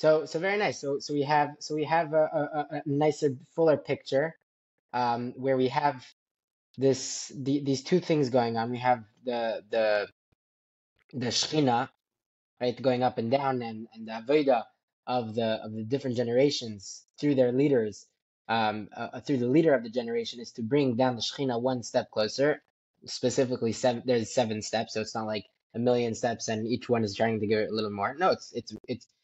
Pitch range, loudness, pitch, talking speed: 110-140 Hz, -28 LUFS, 125 Hz, 195 wpm